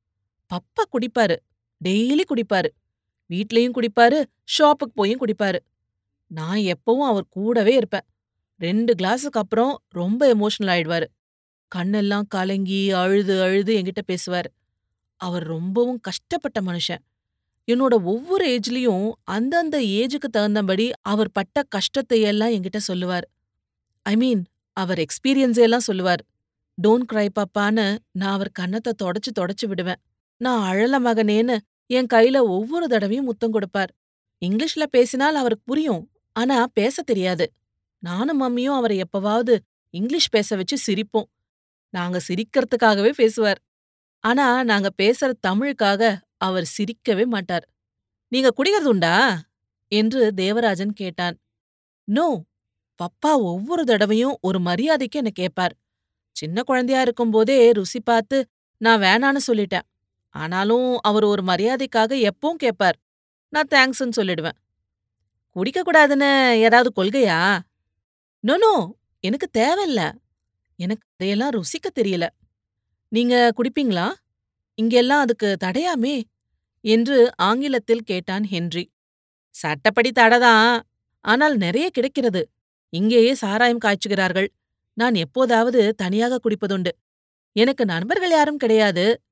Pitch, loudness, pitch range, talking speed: 215 Hz, -20 LUFS, 185-245 Hz, 105 wpm